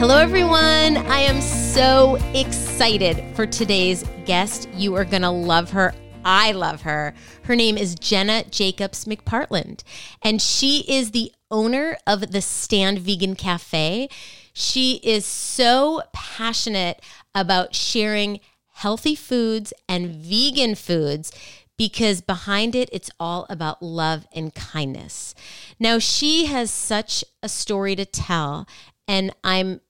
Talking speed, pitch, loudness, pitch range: 130 wpm, 200 Hz, -20 LUFS, 180-235 Hz